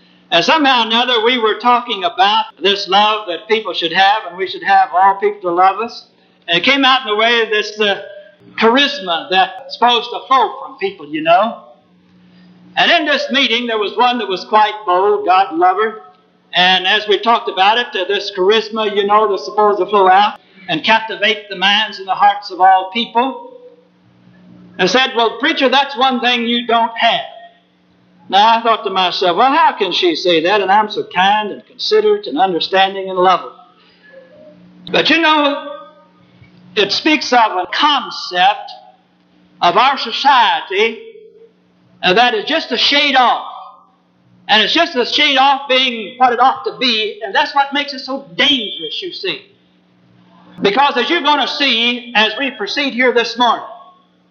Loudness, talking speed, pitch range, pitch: -13 LUFS, 180 wpm, 190-290 Hz, 230 Hz